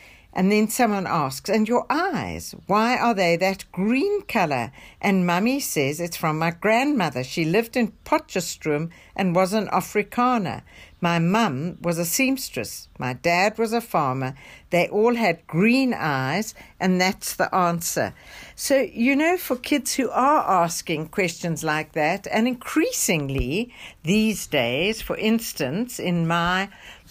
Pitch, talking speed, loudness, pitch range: 190 Hz, 145 wpm, -23 LUFS, 170-230 Hz